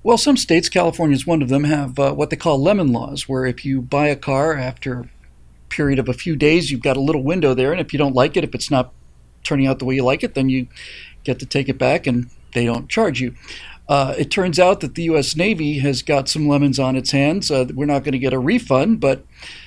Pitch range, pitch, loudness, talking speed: 130-150 Hz, 140 Hz, -18 LUFS, 260 wpm